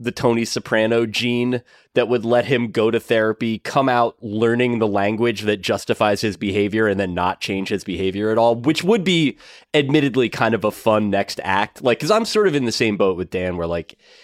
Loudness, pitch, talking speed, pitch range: -19 LUFS, 115 Hz, 215 wpm, 105-125 Hz